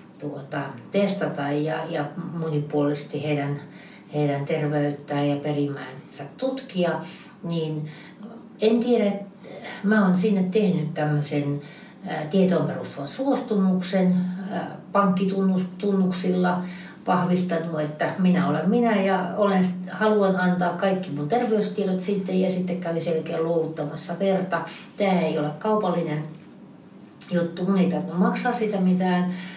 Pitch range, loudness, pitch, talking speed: 155-195 Hz, -24 LUFS, 180 Hz, 110 wpm